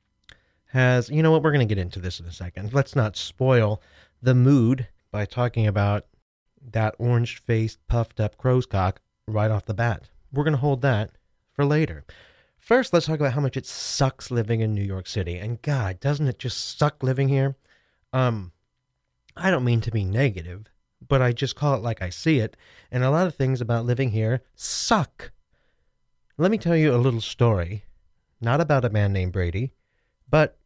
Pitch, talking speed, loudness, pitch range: 120 Hz, 190 wpm, -24 LUFS, 105-135 Hz